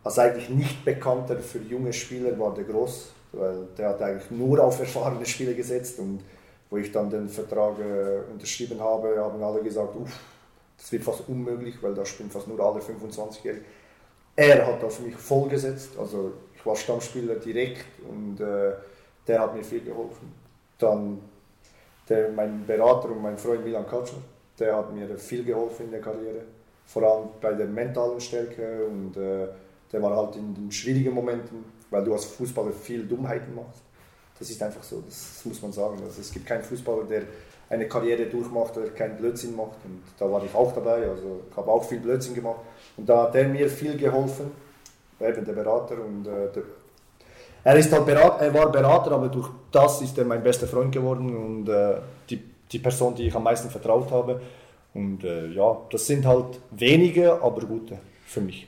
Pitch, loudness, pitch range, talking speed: 115 Hz, -25 LUFS, 105-125 Hz, 185 wpm